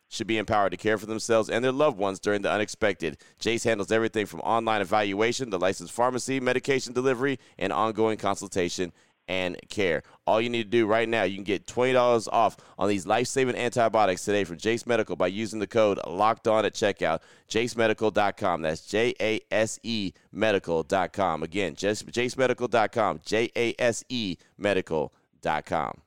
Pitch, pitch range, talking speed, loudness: 110 Hz, 100-120 Hz, 150 wpm, -26 LUFS